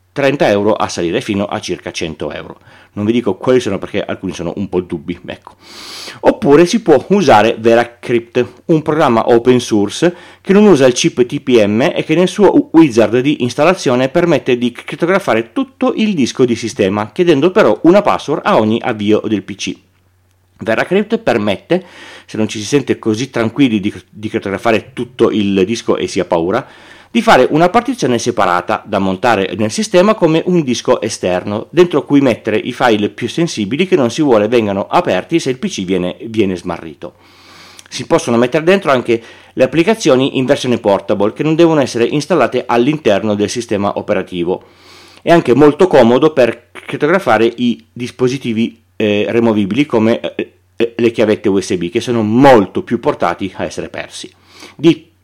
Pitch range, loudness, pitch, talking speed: 105-155 Hz, -13 LUFS, 120 Hz, 165 wpm